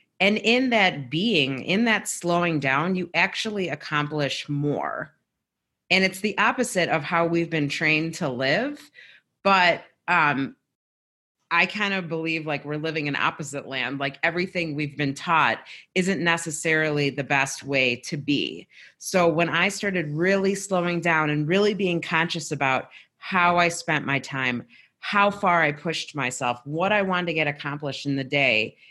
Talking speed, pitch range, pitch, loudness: 160 wpm, 145-180 Hz, 160 Hz, -23 LUFS